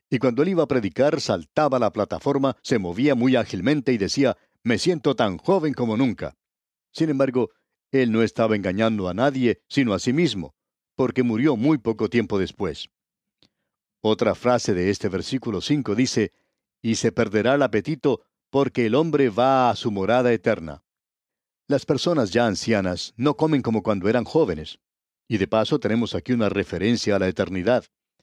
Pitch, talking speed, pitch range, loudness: 120 Hz, 170 wpm, 110-135 Hz, -22 LUFS